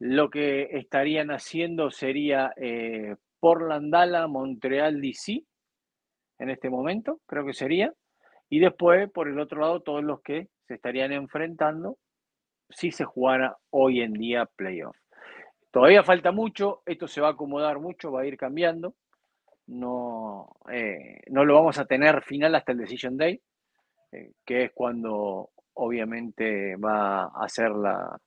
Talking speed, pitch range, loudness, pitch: 140 wpm, 125-165 Hz, -25 LUFS, 140 Hz